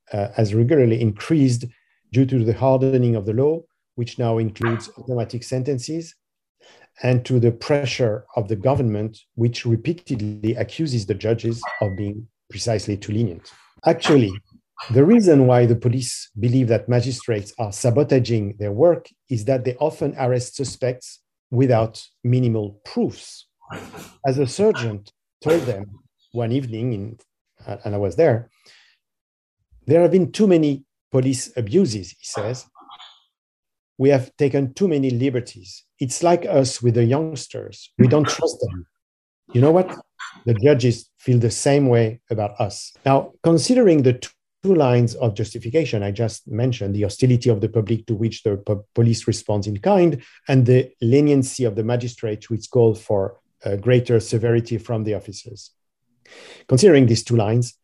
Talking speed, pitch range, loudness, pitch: 150 wpm, 110-135 Hz, -20 LUFS, 120 Hz